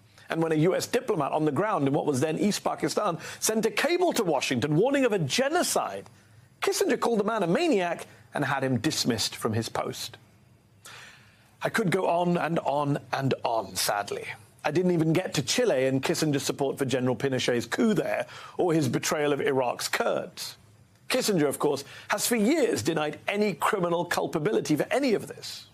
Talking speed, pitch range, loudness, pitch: 185 wpm, 135-210 Hz, -27 LUFS, 160 Hz